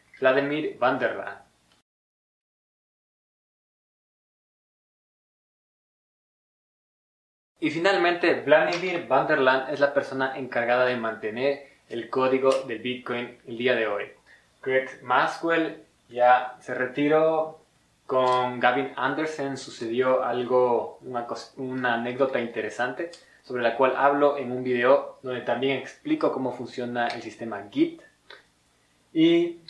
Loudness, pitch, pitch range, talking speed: -25 LUFS, 130 Hz, 125-145 Hz, 105 wpm